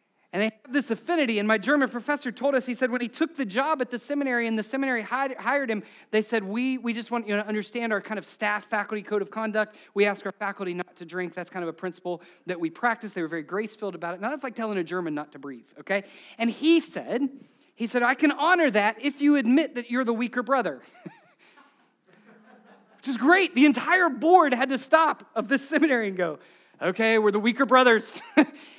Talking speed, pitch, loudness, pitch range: 235 wpm, 235 Hz, -25 LUFS, 205-270 Hz